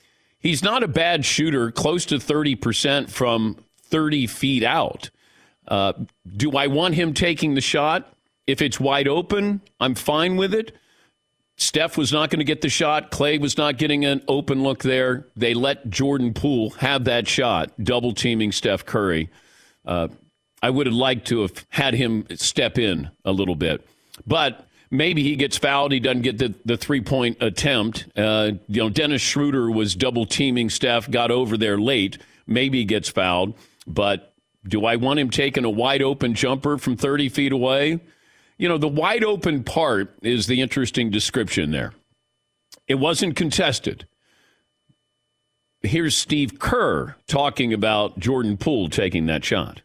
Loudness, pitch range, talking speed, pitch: -21 LUFS, 115-145 Hz, 160 wpm, 130 Hz